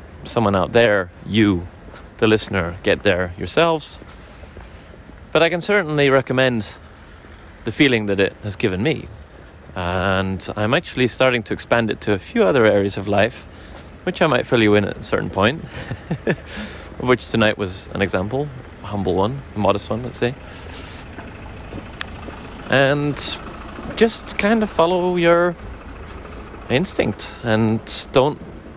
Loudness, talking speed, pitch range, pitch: -19 LUFS, 140 wpm, 90-125 Hz, 105 Hz